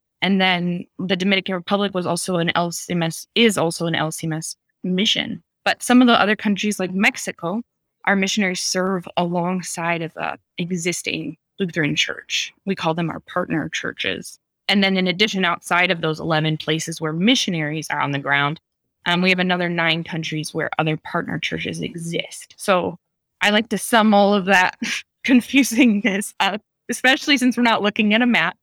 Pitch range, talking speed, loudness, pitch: 165-205 Hz, 170 wpm, -20 LUFS, 180 Hz